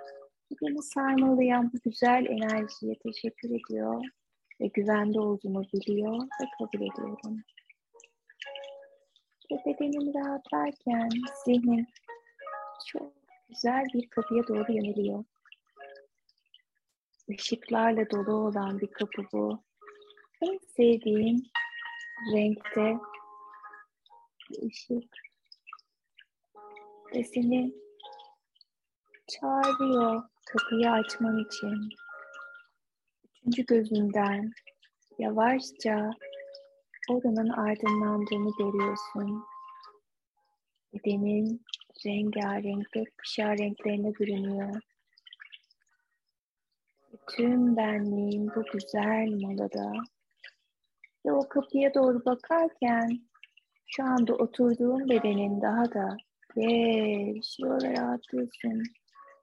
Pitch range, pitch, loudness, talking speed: 210-275 Hz, 230 Hz, -30 LUFS, 70 wpm